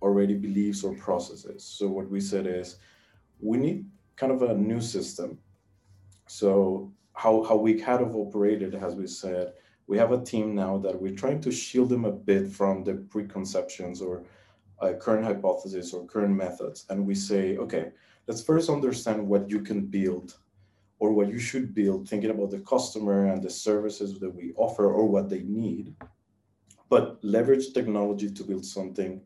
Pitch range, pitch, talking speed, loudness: 95-110 Hz, 100 Hz, 175 wpm, -28 LUFS